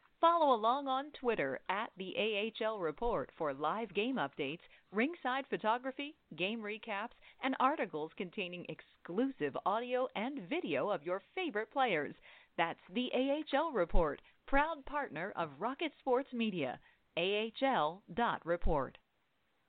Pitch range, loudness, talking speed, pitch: 205-270 Hz, -36 LUFS, 115 wpm, 235 Hz